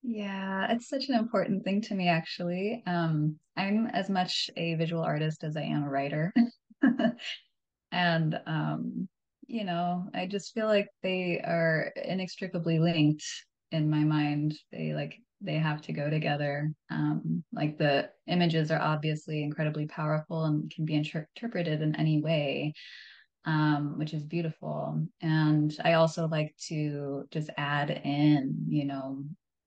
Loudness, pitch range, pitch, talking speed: -30 LUFS, 150-180 Hz, 155 Hz, 150 wpm